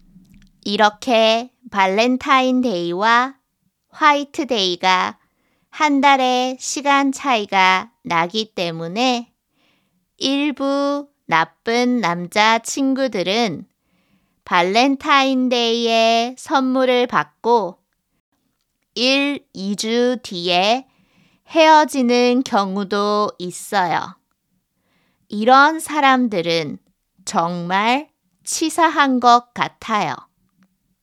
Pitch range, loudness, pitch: 195-270 Hz, -17 LUFS, 240 Hz